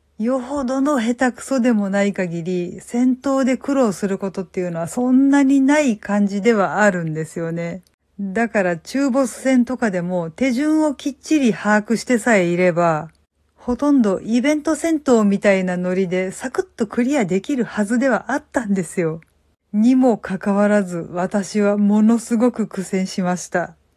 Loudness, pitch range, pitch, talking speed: -19 LUFS, 190-260 Hz, 215 Hz, 330 characters per minute